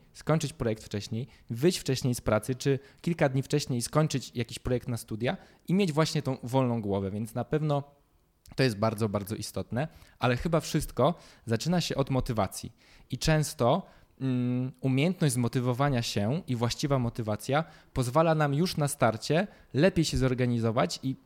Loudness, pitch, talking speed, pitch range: -29 LUFS, 130 Hz, 150 wpm, 120-150 Hz